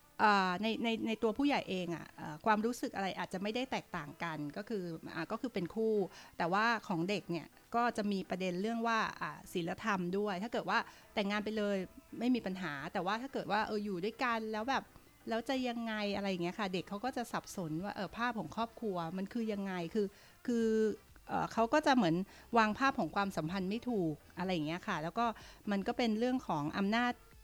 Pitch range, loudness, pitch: 185-230 Hz, -36 LUFS, 210 Hz